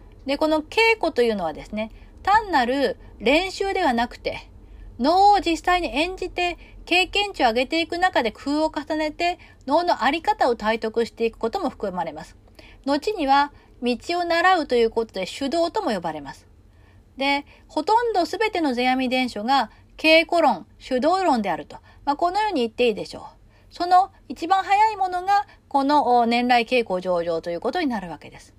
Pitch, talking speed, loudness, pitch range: 290 Hz, 335 characters per minute, -22 LUFS, 240-355 Hz